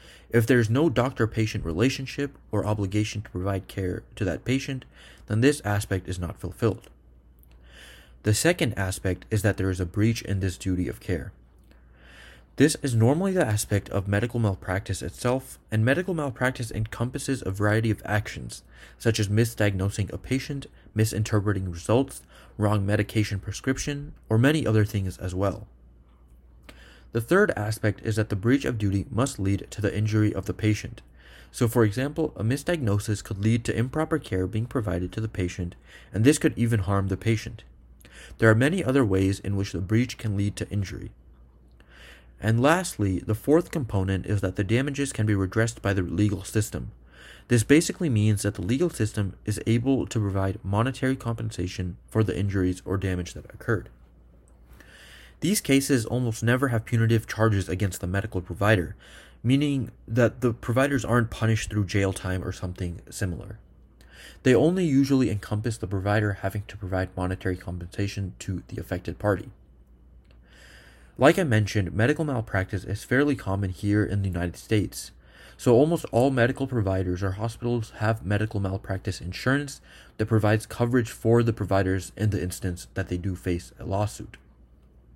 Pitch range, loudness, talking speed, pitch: 95-115 Hz, -26 LUFS, 165 wpm, 105 Hz